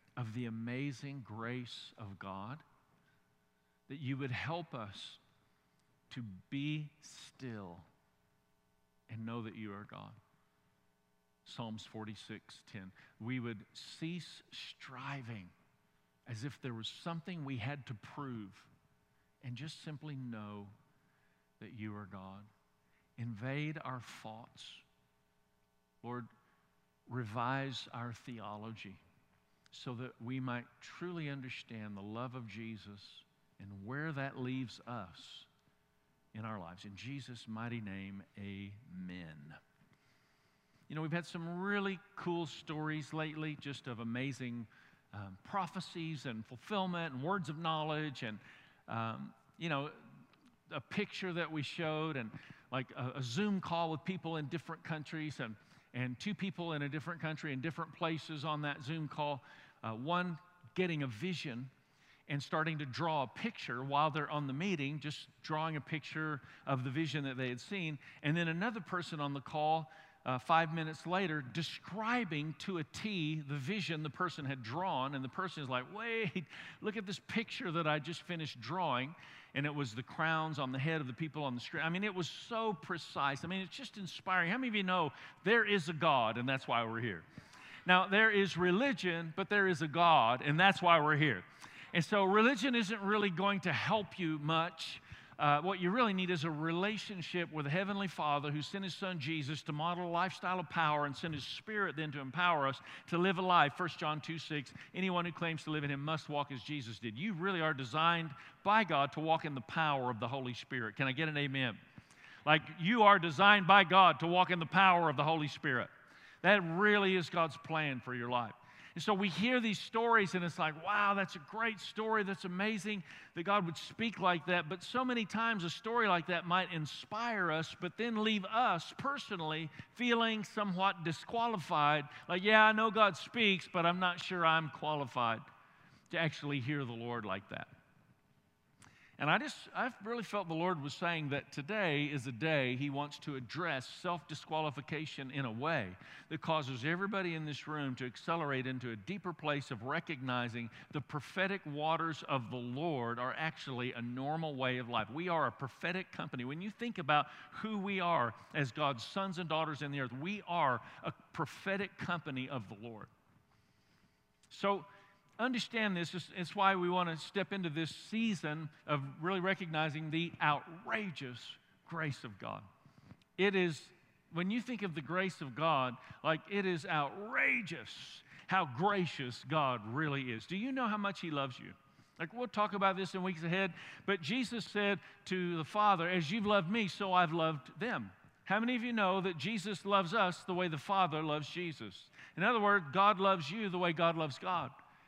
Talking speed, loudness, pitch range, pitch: 180 wpm, -36 LUFS, 130-185 Hz, 155 Hz